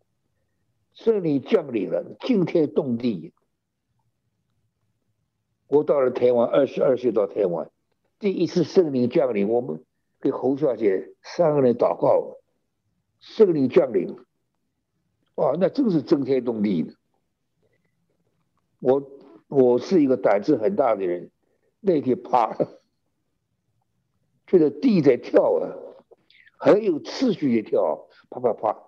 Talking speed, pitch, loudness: 170 characters per minute, 170 Hz, -22 LUFS